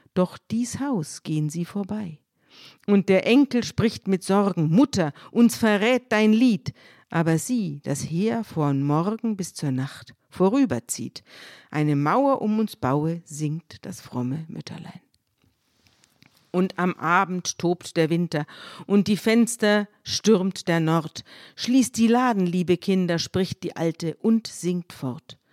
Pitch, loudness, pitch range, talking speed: 180 Hz, -23 LUFS, 155-215 Hz, 140 wpm